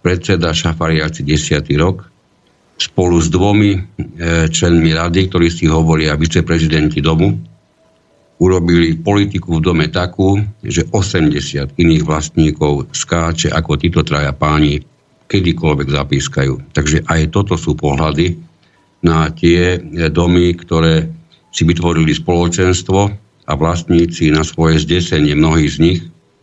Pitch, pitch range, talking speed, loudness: 80 Hz, 75-90 Hz, 115 wpm, -14 LUFS